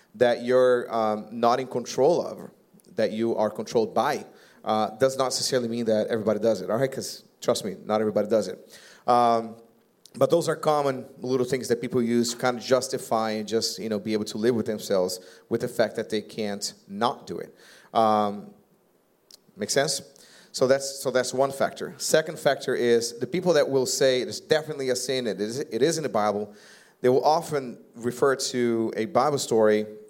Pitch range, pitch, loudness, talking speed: 110-130 Hz, 120 Hz, -25 LUFS, 195 wpm